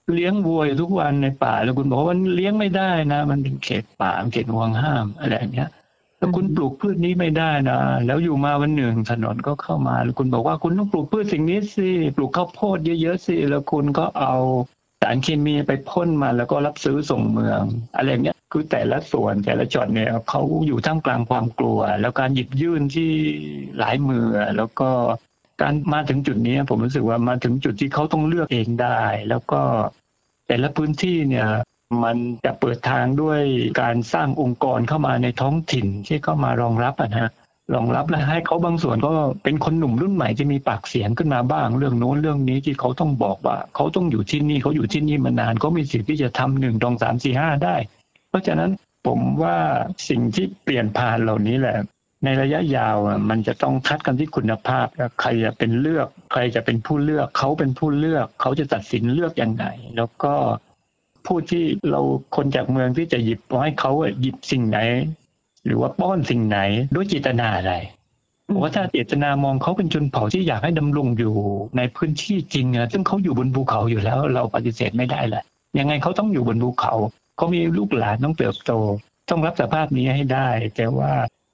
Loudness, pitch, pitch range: -21 LUFS, 135 Hz, 115-155 Hz